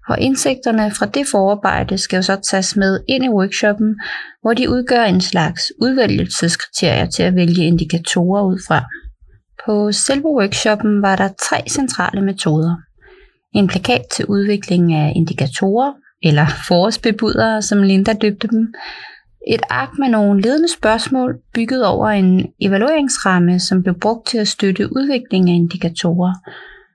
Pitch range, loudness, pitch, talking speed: 180-235 Hz, -15 LUFS, 205 Hz, 140 wpm